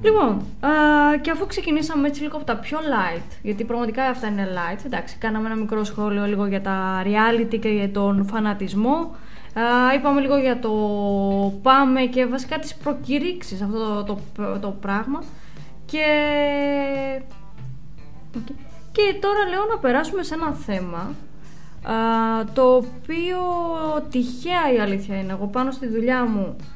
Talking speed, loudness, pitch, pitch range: 150 wpm, -22 LUFS, 240 Hz, 205-295 Hz